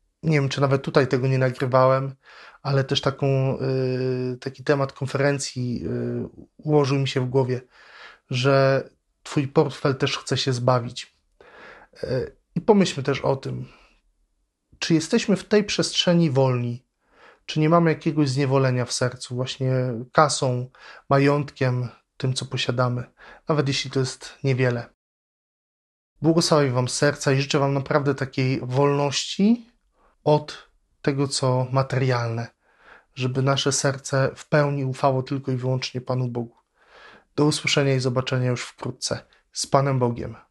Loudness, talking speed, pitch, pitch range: -23 LUFS, 135 wpm, 135 Hz, 130-145 Hz